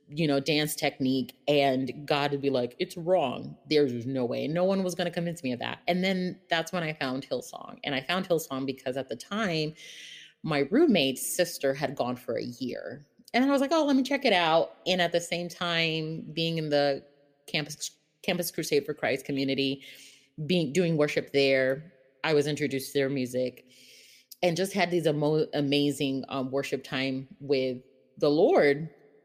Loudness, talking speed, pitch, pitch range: -28 LUFS, 185 wpm, 145 Hz, 135-170 Hz